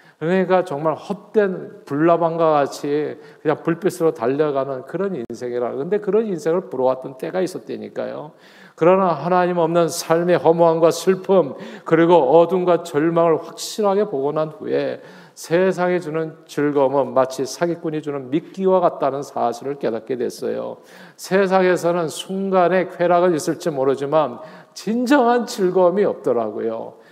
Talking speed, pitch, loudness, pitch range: 320 characters per minute, 170 Hz, -19 LUFS, 155-185 Hz